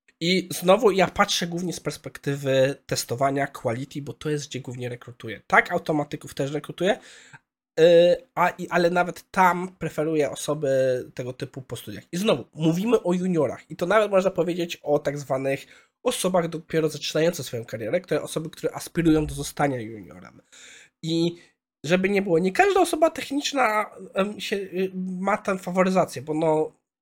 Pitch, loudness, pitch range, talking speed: 165 Hz, -24 LUFS, 140-185 Hz, 155 wpm